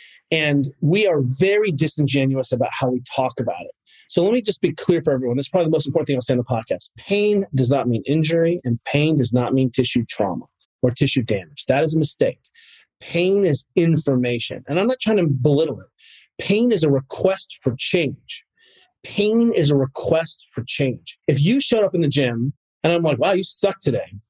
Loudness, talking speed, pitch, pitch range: -20 LUFS, 210 wpm, 155 Hz, 130-190 Hz